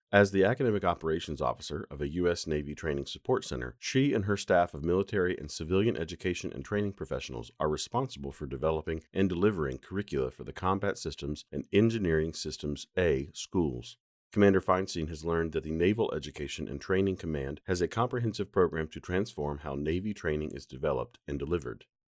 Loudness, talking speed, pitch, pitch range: -31 LUFS, 175 wpm, 85 Hz, 75-95 Hz